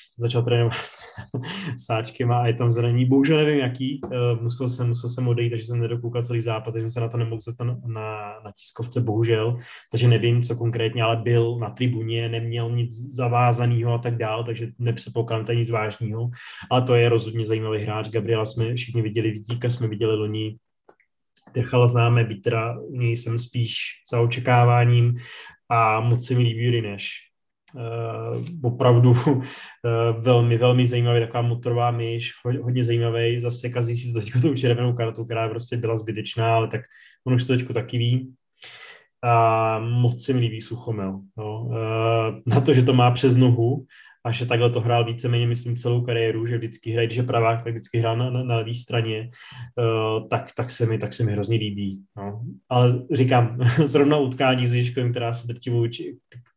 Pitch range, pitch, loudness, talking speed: 115-120 Hz, 120 Hz, -23 LUFS, 175 wpm